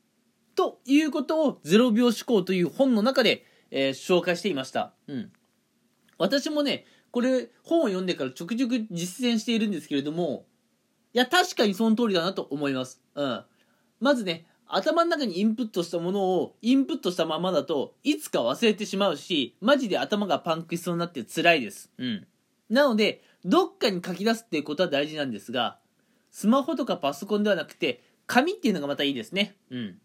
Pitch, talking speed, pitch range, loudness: 210 Hz, 390 characters per minute, 175-255 Hz, -26 LUFS